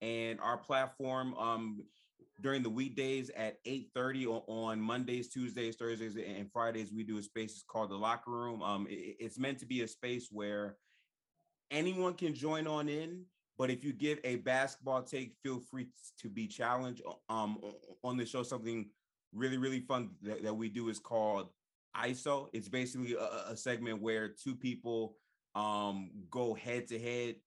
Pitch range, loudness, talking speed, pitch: 110-130 Hz, -39 LUFS, 175 wpm, 120 Hz